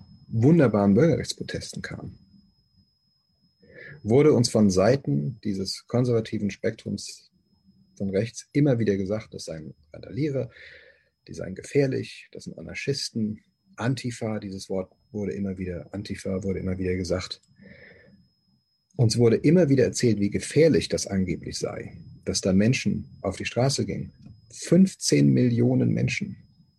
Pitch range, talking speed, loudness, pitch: 95-125 Hz, 125 wpm, -24 LUFS, 105 Hz